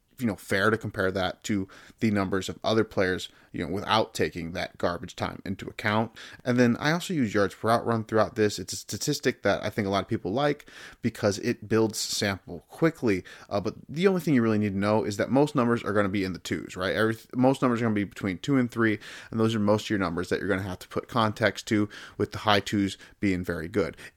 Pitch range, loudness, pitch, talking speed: 100-120 Hz, -27 LUFS, 110 Hz, 260 wpm